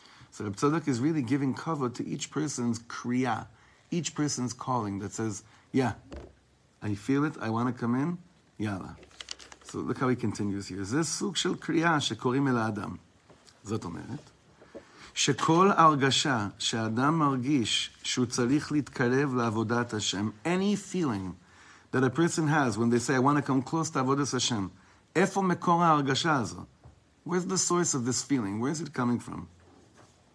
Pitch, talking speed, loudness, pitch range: 125 Hz, 145 wpm, -28 LUFS, 110-150 Hz